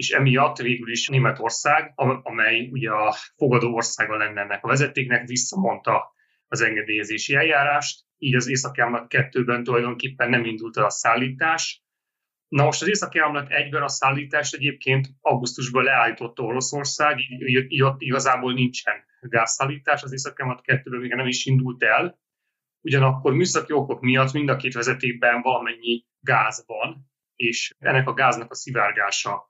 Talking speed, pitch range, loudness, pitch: 160 wpm, 120-145 Hz, -22 LUFS, 130 Hz